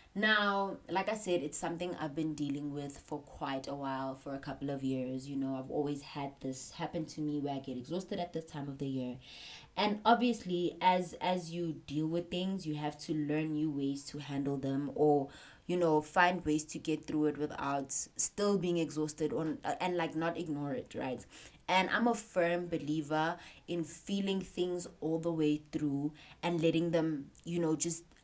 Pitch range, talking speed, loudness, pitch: 145-175 Hz, 200 wpm, -35 LUFS, 155 Hz